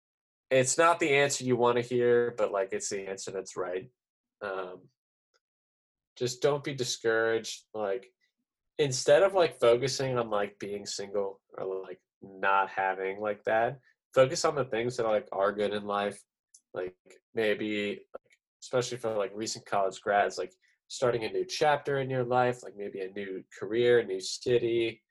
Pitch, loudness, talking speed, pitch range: 115 Hz, -29 LUFS, 165 wpm, 100-130 Hz